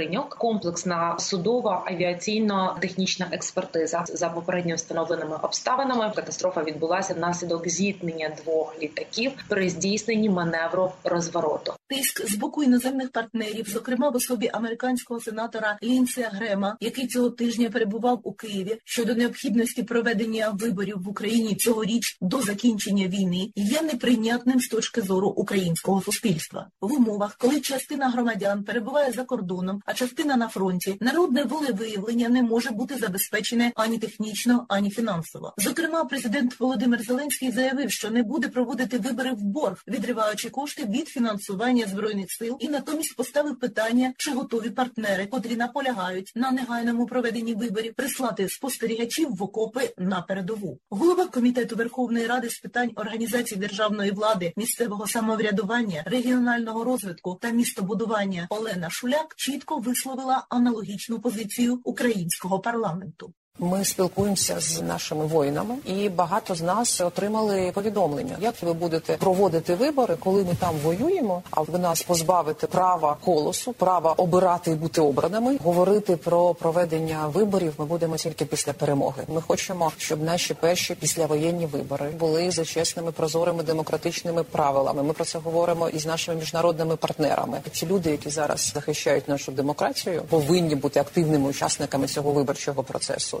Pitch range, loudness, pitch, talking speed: 175-240 Hz, -25 LUFS, 210 Hz, 135 wpm